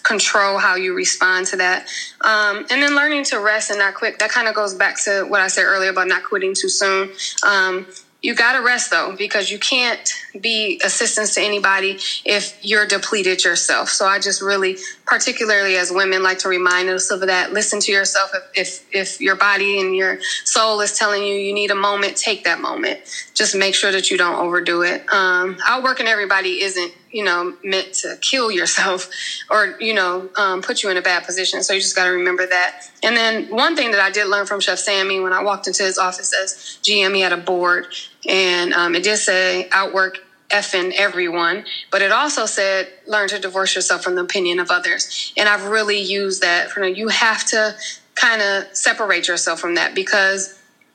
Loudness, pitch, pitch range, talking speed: -17 LUFS, 195 Hz, 185-215 Hz, 210 wpm